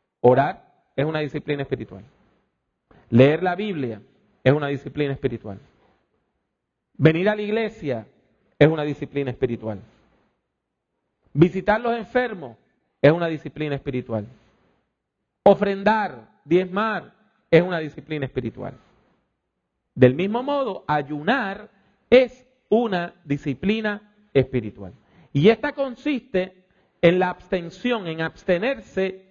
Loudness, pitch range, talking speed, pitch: -22 LUFS, 140-210 Hz, 100 wpm, 165 Hz